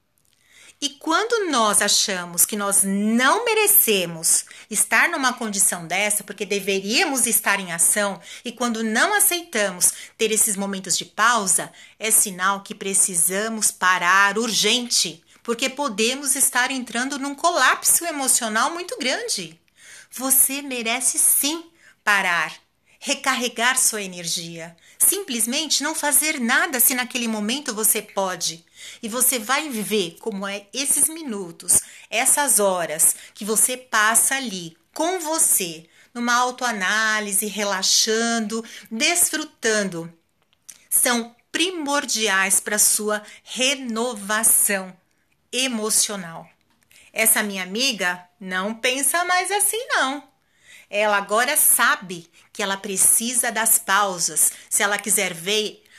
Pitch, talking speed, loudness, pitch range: 220 Hz, 110 wpm, -19 LUFS, 200-260 Hz